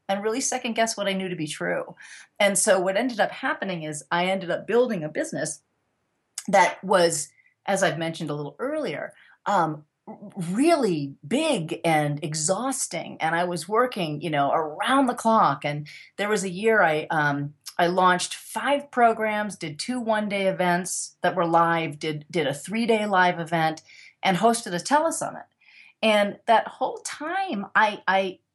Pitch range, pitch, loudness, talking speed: 165-220 Hz, 190 Hz, -24 LUFS, 170 wpm